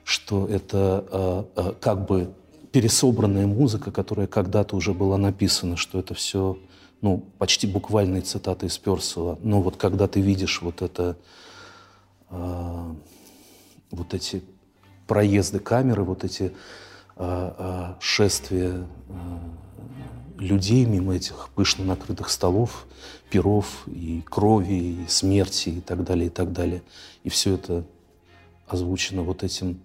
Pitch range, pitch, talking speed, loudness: 90-100 Hz, 95 Hz, 125 wpm, -24 LUFS